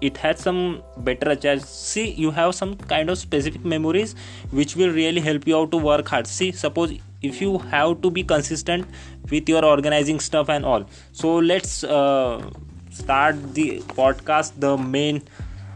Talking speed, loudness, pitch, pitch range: 170 wpm, -21 LUFS, 150 Hz, 135-160 Hz